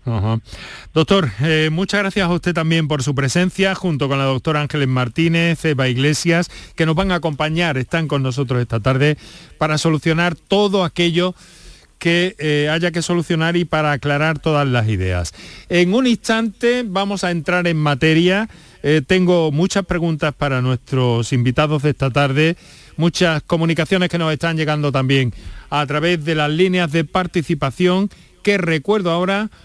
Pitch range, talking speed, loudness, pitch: 145-175 Hz, 160 wpm, -17 LUFS, 160 Hz